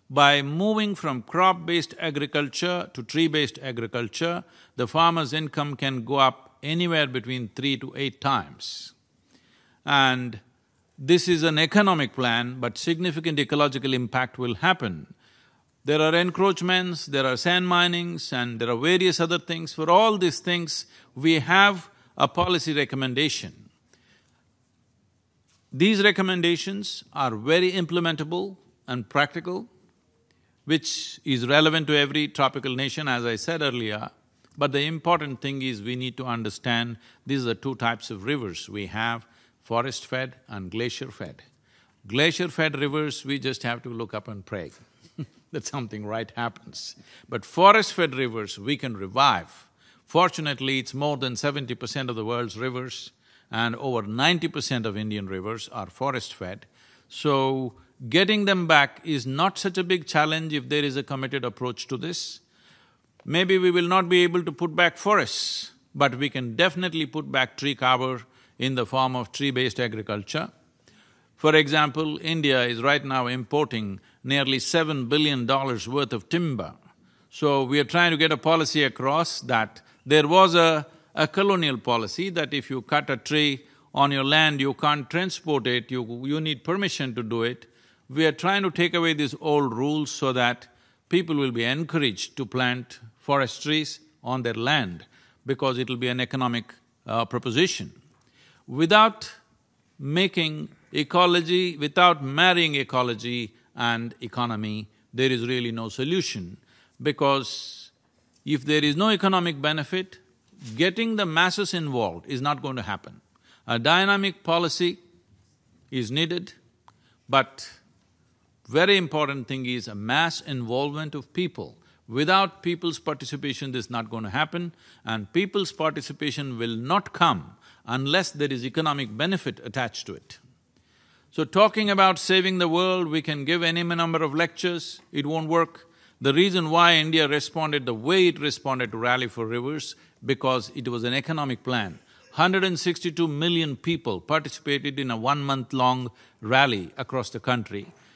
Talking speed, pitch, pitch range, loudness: 150 wpm, 140 Hz, 125-165 Hz, -24 LUFS